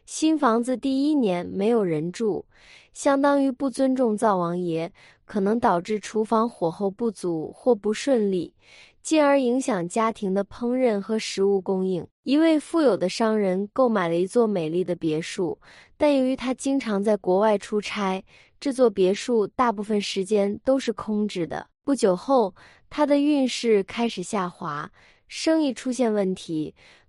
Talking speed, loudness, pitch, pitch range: 235 characters per minute, -24 LUFS, 220 Hz, 195-260 Hz